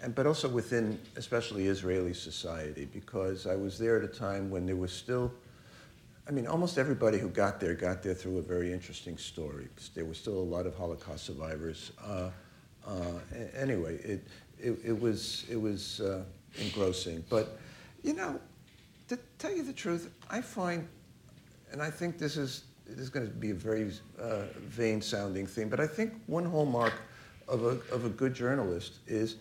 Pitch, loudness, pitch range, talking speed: 110 Hz, -35 LUFS, 90-130 Hz, 180 wpm